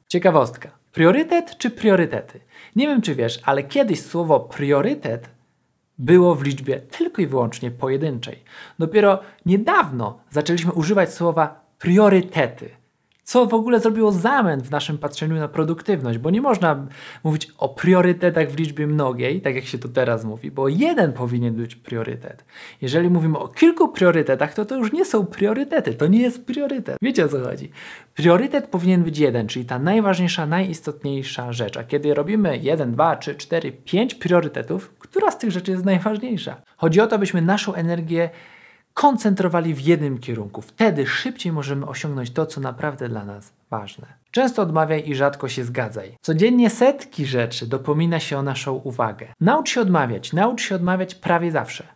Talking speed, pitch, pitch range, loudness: 160 wpm, 165 Hz, 135-200 Hz, -20 LUFS